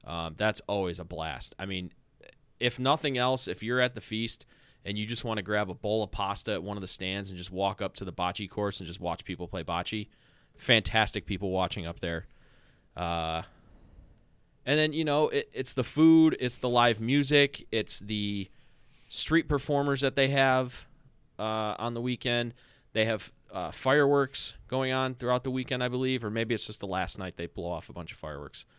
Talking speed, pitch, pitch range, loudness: 205 wpm, 110 Hz, 95-130 Hz, -29 LUFS